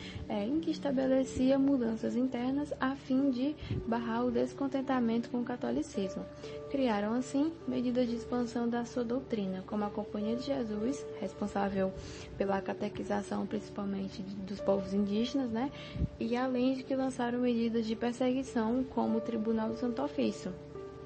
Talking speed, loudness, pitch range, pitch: 140 wpm, -34 LUFS, 205-260 Hz, 235 Hz